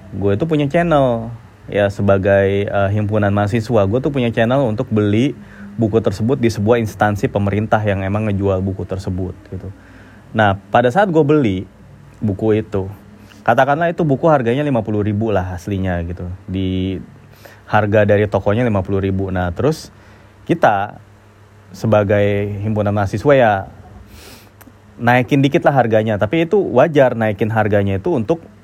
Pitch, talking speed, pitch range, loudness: 105 Hz, 135 wpm, 100-120 Hz, -16 LUFS